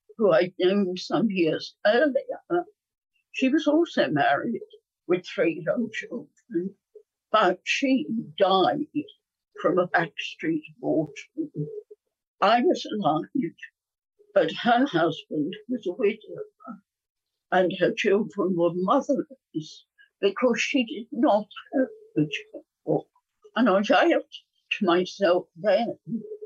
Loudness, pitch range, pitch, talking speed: -25 LUFS, 185-305 Hz, 235 Hz, 110 wpm